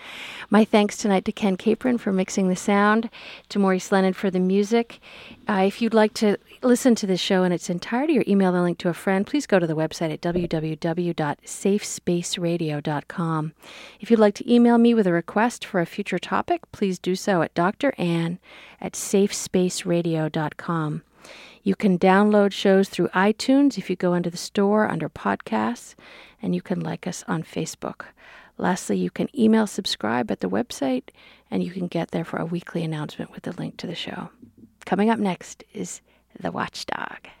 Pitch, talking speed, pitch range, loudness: 190 Hz, 180 wpm, 175-215 Hz, -23 LUFS